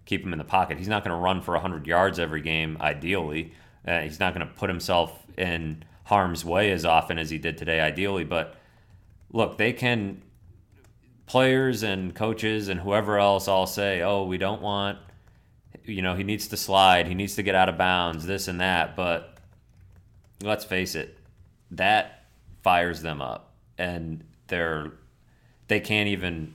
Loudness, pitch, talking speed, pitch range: -25 LUFS, 95 Hz, 175 wpm, 85-100 Hz